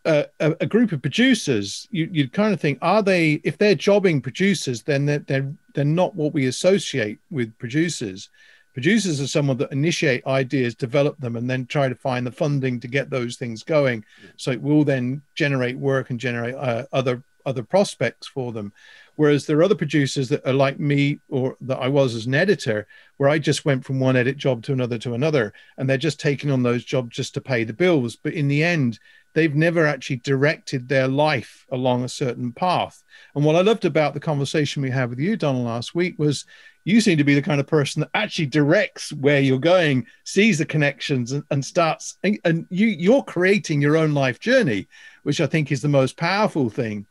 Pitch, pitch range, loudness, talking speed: 145 Hz, 130-160 Hz, -21 LUFS, 210 wpm